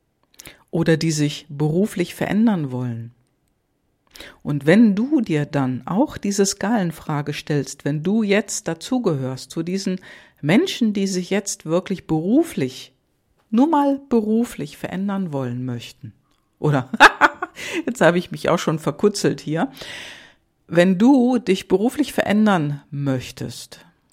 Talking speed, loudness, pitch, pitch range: 120 wpm, -20 LUFS, 175 Hz, 145-215 Hz